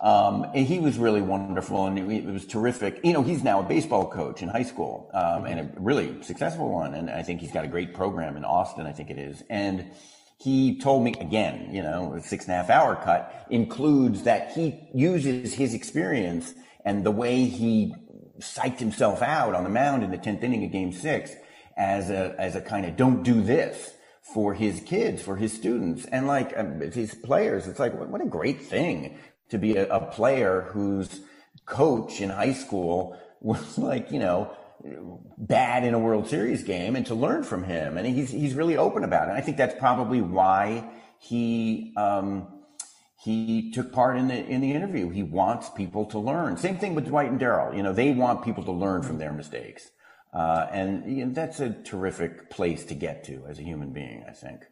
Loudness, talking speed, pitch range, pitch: -26 LUFS, 210 wpm, 95-130 Hz, 110 Hz